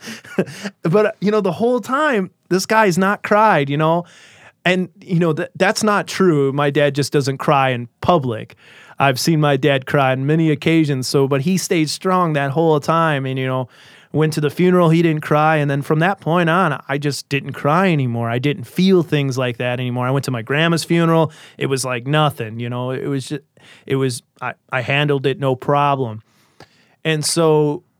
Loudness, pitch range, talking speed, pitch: -17 LUFS, 135-175 Hz, 205 wpm, 150 Hz